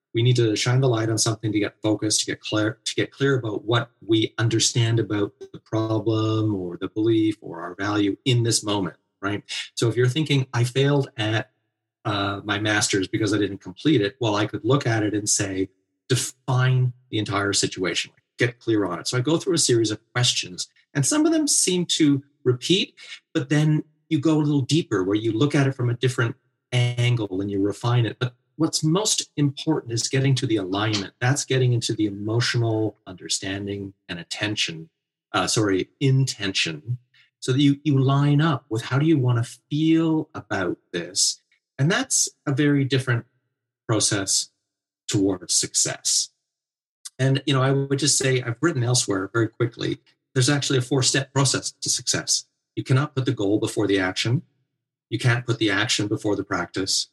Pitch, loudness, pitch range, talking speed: 120 Hz, -23 LUFS, 105-140 Hz, 190 wpm